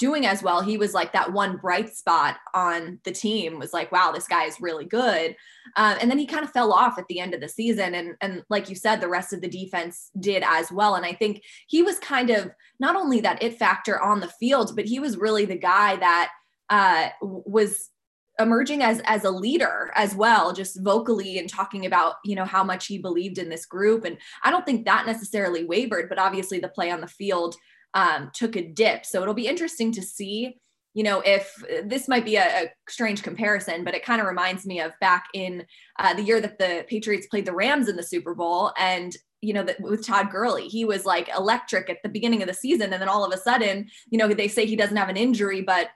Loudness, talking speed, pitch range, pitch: -23 LUFS, 240 wpm, 185-225 Hz, 200 Hz